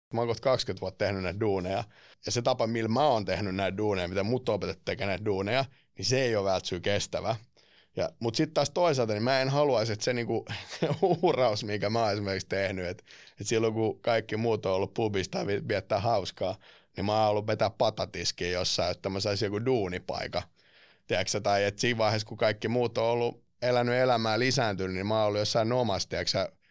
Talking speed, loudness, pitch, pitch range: 205 wpm, -29 LUFS, 110 Hz, 100-120 Hz